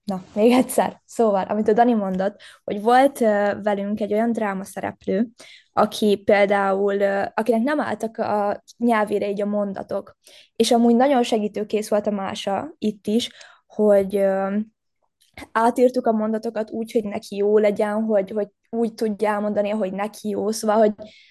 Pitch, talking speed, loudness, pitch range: 215 Hz, 150 wpm, -21 LUFS, 205-230 Hz